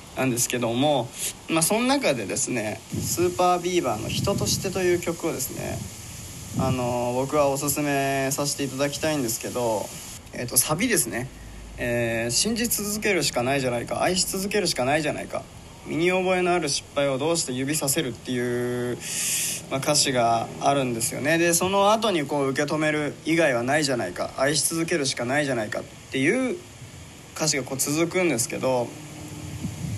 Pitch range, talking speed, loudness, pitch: 125-175 Hz, 370 characters per minute, -24 LUFS, 145 Hz